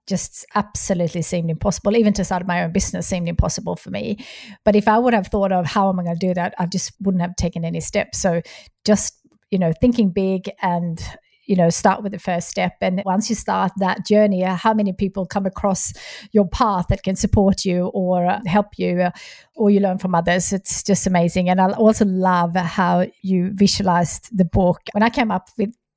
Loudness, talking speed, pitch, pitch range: -19 LUFS, 210 wpm, 190 Hz, 180-205 Hz